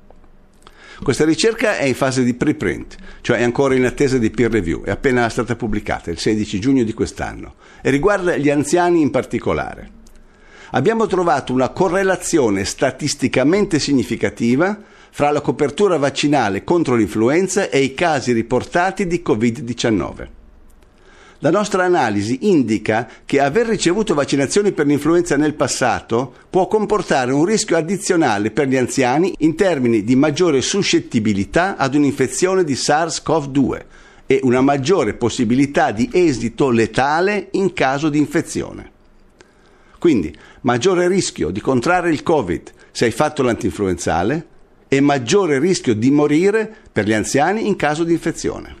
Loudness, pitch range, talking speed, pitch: -17 LUFS, 120-180 Hz, 135 wpm, 145 Hz